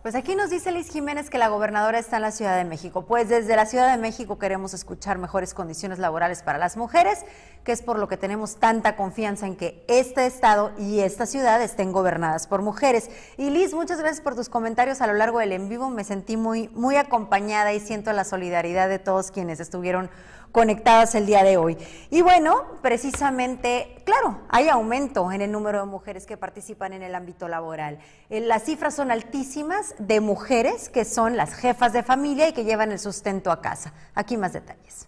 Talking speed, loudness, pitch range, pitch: 200 wpm, -23 LUFS, 190-245 Hz, 220 Hz